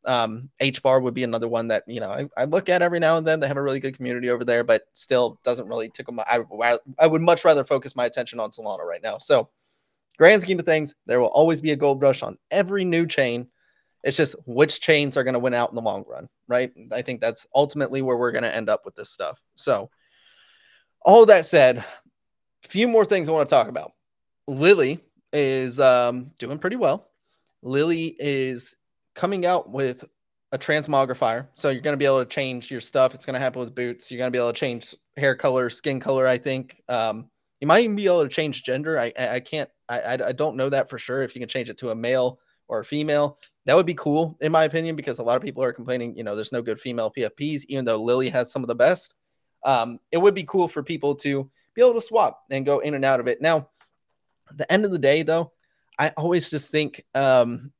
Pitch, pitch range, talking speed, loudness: 135 Hz, 125-155 Hz, 240 wpm, -22 LUFS